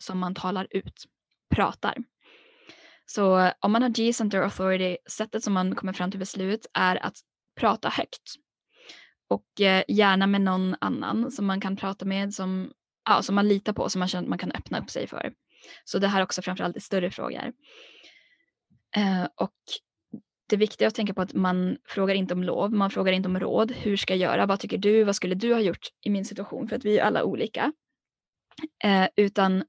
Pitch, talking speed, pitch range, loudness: 195 Hz, 195 wpm, 185-220 Hz, -26 LUFS